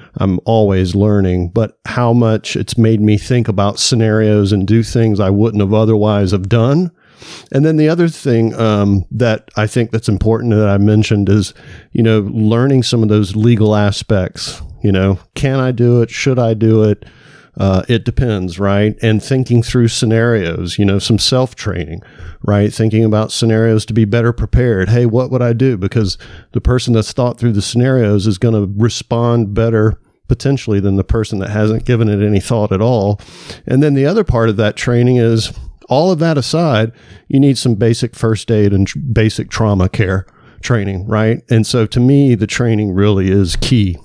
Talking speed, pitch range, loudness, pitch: 190 wpm, 105-120 Hz, -13 LUFS, 110 Hz